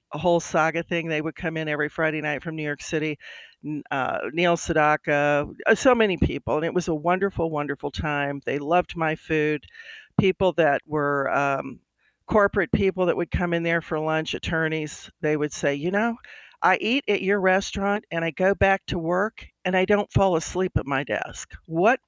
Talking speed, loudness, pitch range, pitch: 195 wpm, -24 LUFS, 150-190 Hz, 165 Hz